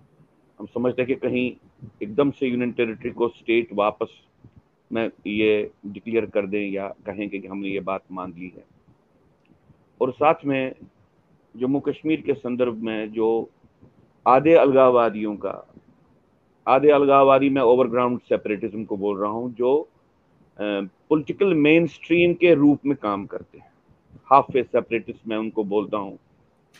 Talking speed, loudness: 140 wpm, -22 LUFS